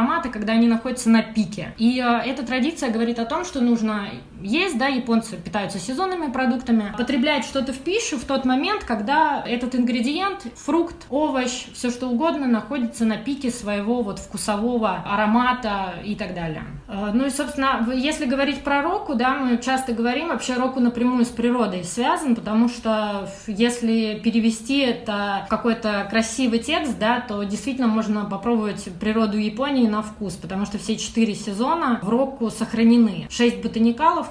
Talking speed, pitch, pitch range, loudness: 155 wpm, 235 Hz, 215-260 Hz, -22 LUFS